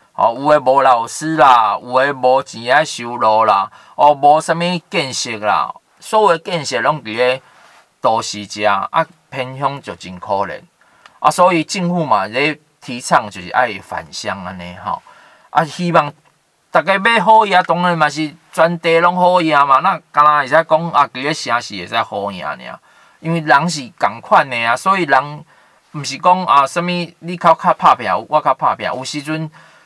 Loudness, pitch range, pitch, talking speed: -15 LUFS, 130-170 Hz, 150 Hz, 245 characters per minute